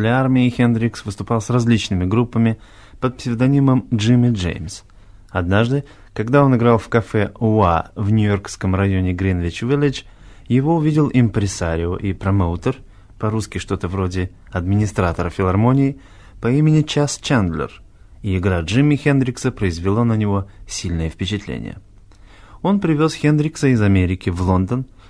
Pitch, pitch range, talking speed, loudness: 105 Hz, 95-125 Hz, 125 wpm, -18 LUFS